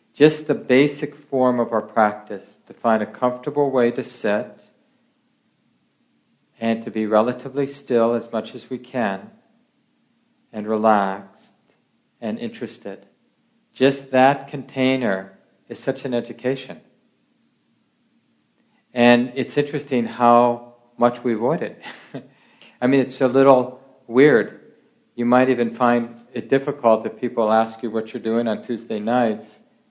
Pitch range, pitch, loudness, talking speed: 115-140 Hz, 125 Hz, -20 LUFS, 130 wpm